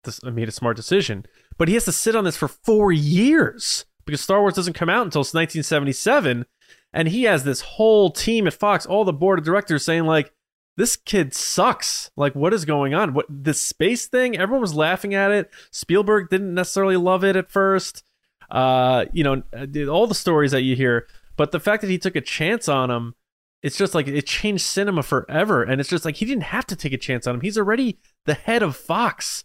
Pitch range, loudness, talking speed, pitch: 145-200 Hz, -20 LUFS, 220 wpm, 170 Hz